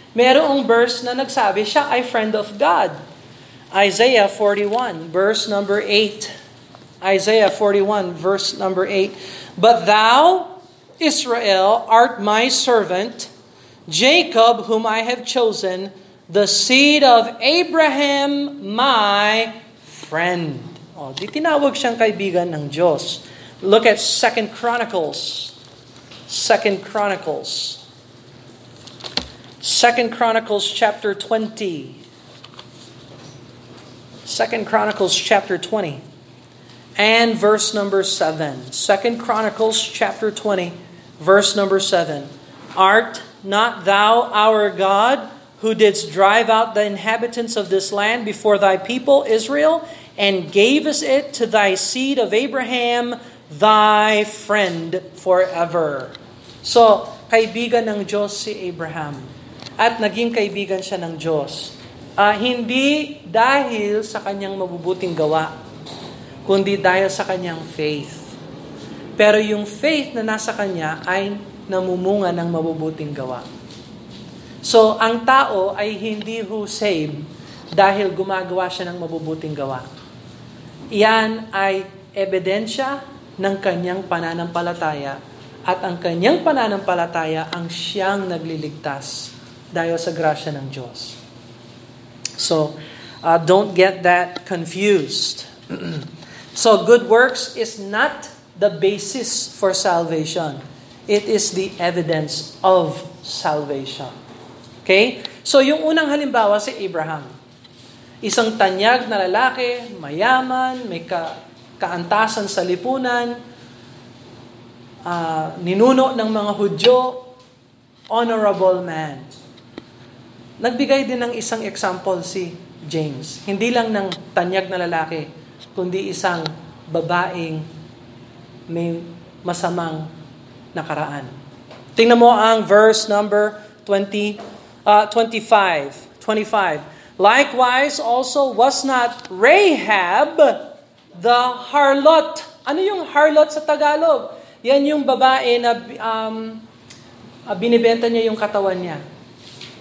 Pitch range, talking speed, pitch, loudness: 160-225 Hz, 105 wpm, 200 Hz, -17 LUFS